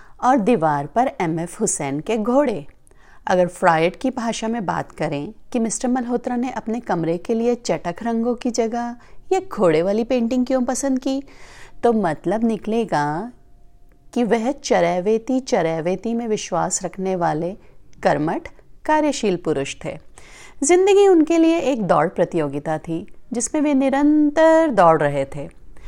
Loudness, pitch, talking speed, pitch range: -20 LUFS, 225 Hz, 145 wpm, 170-255 Hz